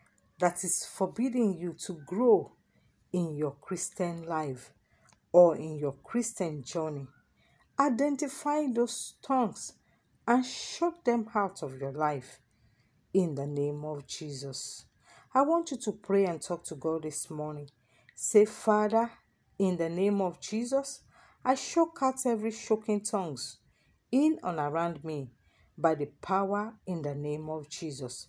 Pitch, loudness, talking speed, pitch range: 175 Hz, -31 LUFS, 140 wpm, 150-225 Hz